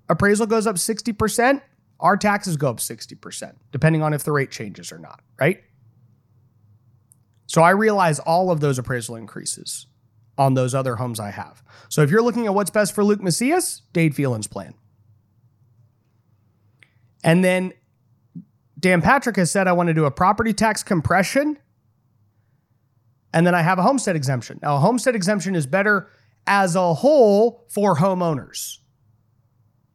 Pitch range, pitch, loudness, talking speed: 120-195 Hz, 150 Hz, -20 LUFS, 155 wpm